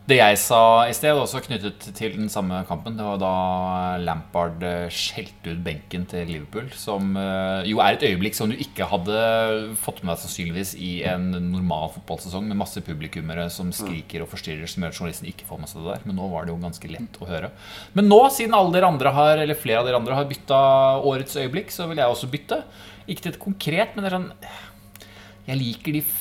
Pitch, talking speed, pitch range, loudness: 105 Hz, 220 wpm, 90-135 Hz, -22 LUFS